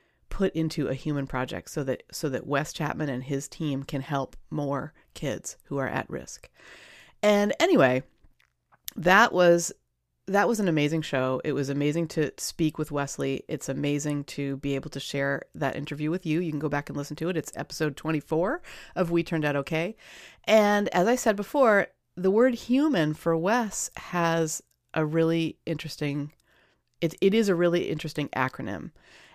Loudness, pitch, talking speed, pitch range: -27 LUFS, 155 Hz, 175 wpm, 140-175 Hz